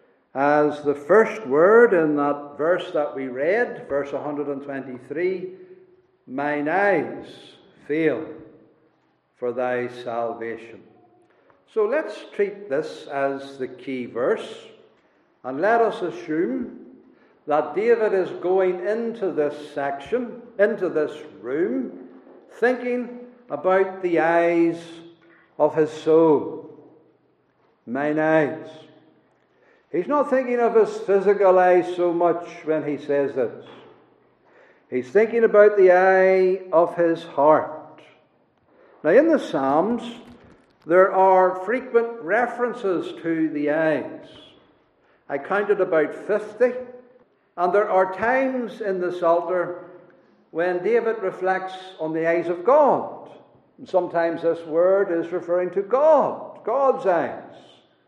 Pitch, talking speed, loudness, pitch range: 180 Hz, 115 wpm, -21 LUFS, 155-230 Hz